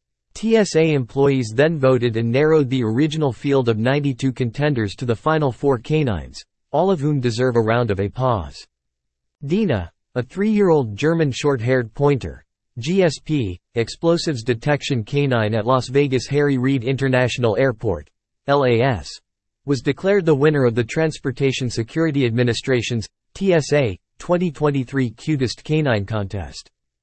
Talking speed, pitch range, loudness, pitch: 125 wpm, 115-150 Hz, -19 LUFS, 130 Hz